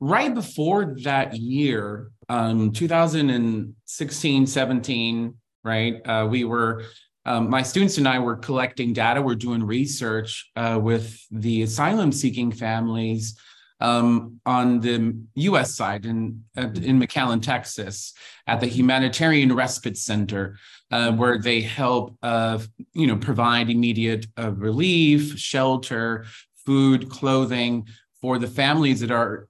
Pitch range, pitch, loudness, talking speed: 115-130 Hz, 120 Hz, -22 LUFS, 120 wpm